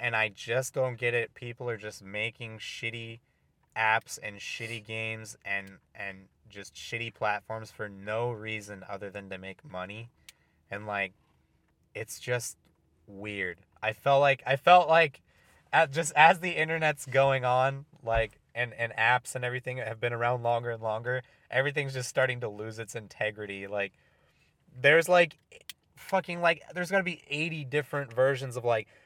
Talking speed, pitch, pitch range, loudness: 160 wpm, 120 Hz, 105-135 Hz, -29 LUFS